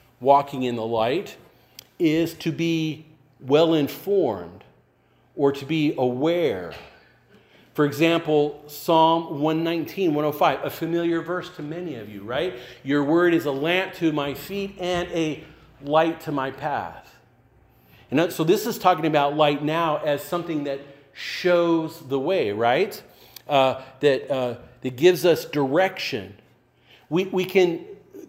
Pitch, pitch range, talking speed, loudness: 155 Hz, 140-170 Hz, 140 wpm, -23 LUFS